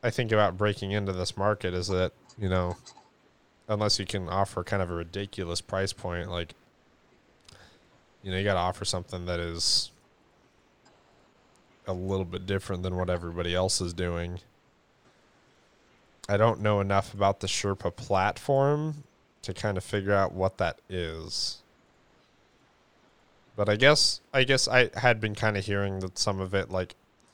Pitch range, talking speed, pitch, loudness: 90-105 Hz, 160 wpm, 100 Hz, -28 LUFS